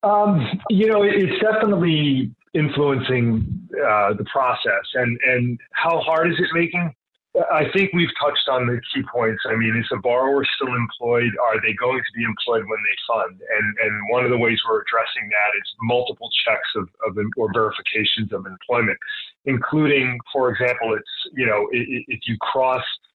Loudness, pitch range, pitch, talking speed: -20 LUFS, 120-160 Hz, 130 Hz, 175 wpm